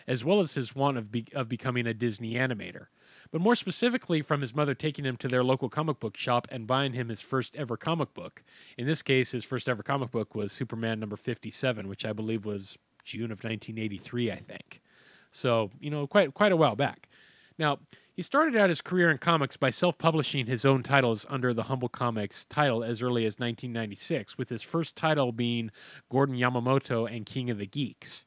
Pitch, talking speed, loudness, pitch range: 130 Hz, 205 wpm, -29 LUFS, 115-145 Hz